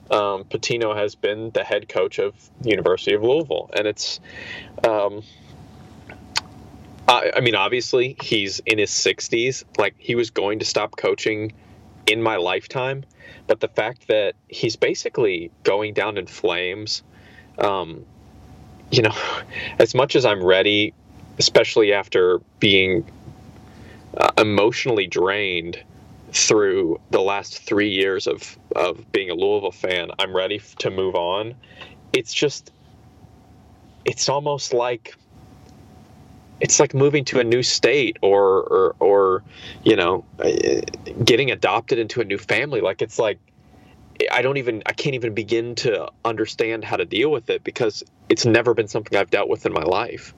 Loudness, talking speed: -20 LUFS, 145 wpm